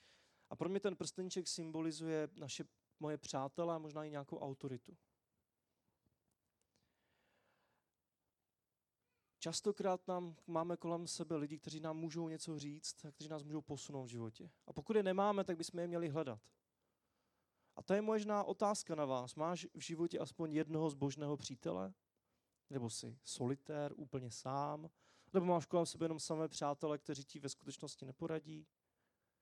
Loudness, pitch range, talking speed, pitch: -43 LUFS, 145-170 Hz, 145 wpm, 160 Hz